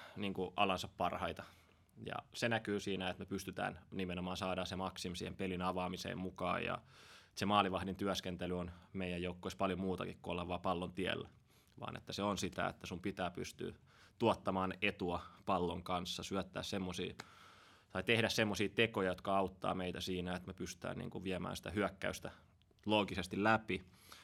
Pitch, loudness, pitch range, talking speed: 95 Hz, -40 LUFS, 90-100 Hz, 165 wpm